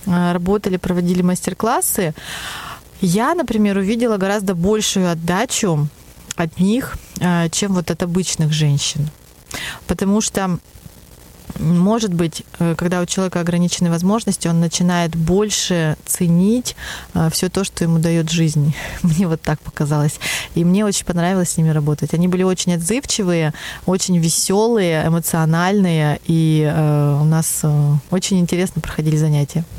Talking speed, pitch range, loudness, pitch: 120 wpm, 160-190 Hz, -17 LUFS, 175 Hz